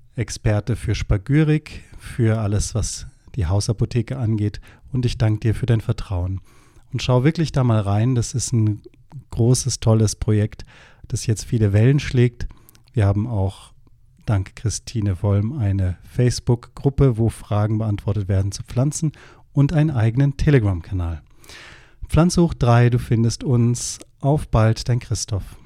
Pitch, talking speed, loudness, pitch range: 115 Hz, 140 wpm, -20 LUFS, 105-125 Hz